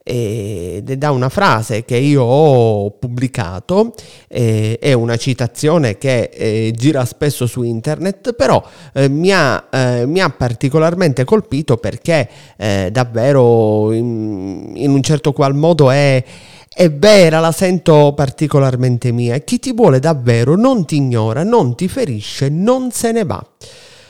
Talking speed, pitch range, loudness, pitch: 145 wpm, 120-160 Hz, -14 LUFS, 135 Hz